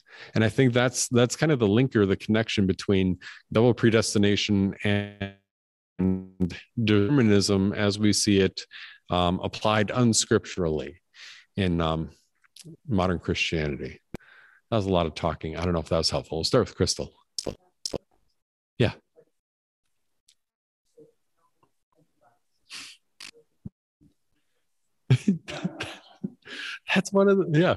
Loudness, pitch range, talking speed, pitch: -25 LUFS, 90-120 Hz, 110 wpm, 100 Hz